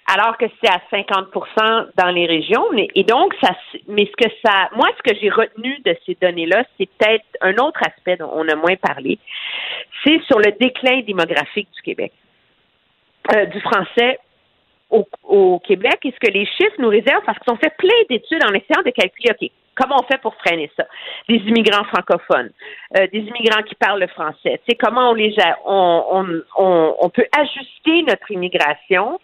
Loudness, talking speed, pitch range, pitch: -16 LUFS, 195 wpm, 190-275 Hz, 225 Hz